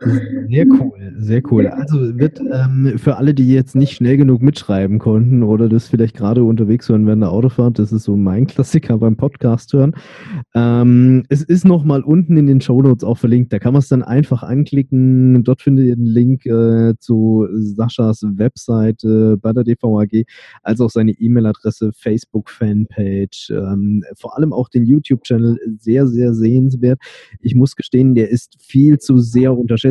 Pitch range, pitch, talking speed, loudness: 110-135 Hz, 120 Hz, 175 wpm, -14 LUFS